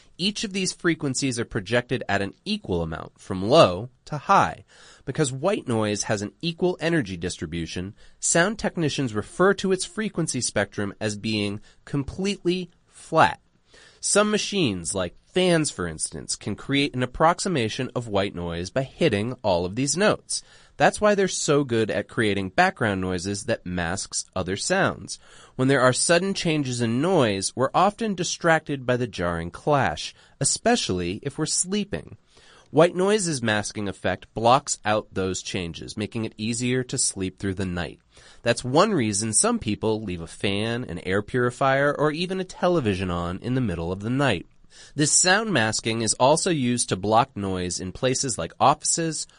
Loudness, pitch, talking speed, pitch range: -24 LUFS, 125 Hz, 165 wpm, 100-165 Hz